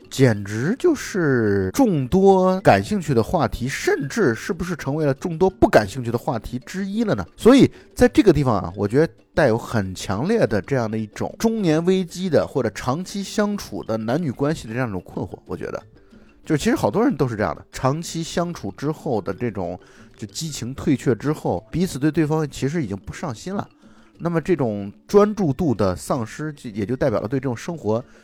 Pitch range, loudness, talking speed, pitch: 110-180 Hz, -21 LUFS, 305 characters per minute, 140 Hz